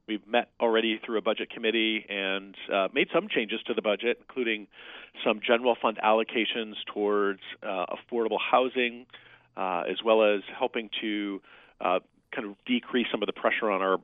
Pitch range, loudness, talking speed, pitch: 105-120 Hz, -28 LUFS, 170 wpm, 110 Hz